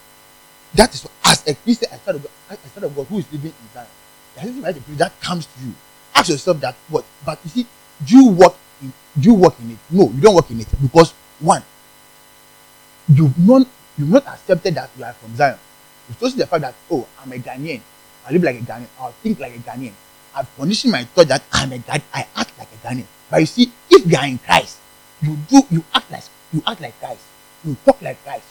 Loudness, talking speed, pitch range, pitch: -16 LUFS, 225 wpm, 140-185 Hz, 145 Hz